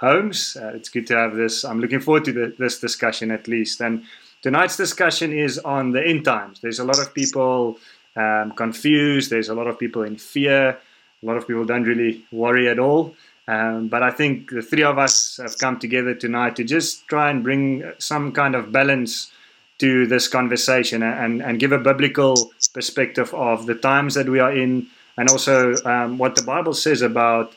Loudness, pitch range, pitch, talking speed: -19 LUFS, 115-140 Hz, 125 Hz, 200 wpm